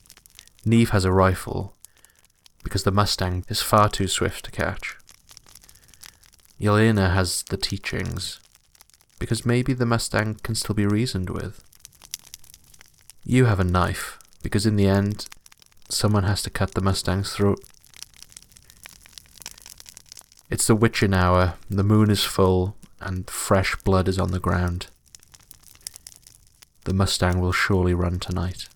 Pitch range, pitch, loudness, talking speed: 90-105 Hz, 95 Hz, -22 LUFS, 130 wpm